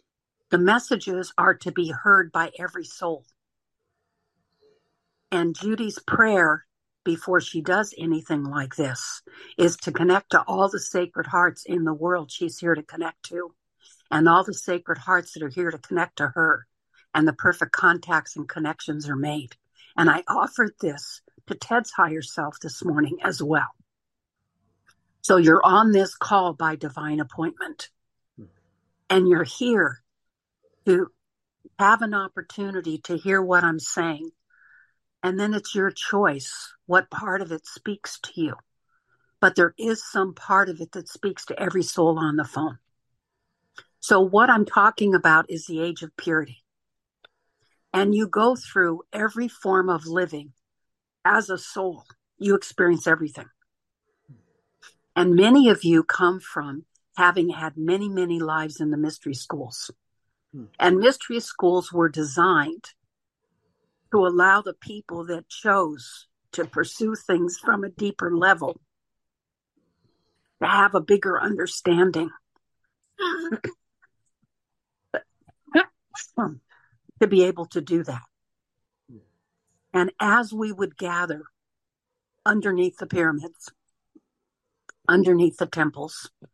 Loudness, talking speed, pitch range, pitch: -22 LUFS, 135 wpm, 160-195 Hz, 175 Hz